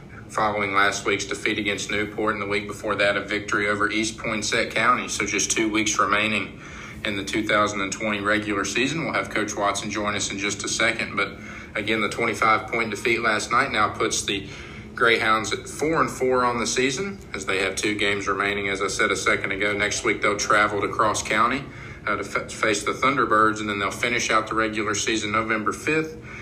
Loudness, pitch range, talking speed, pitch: -23 LUFS, 100-110 Hz, 205 wpm, 105 Hz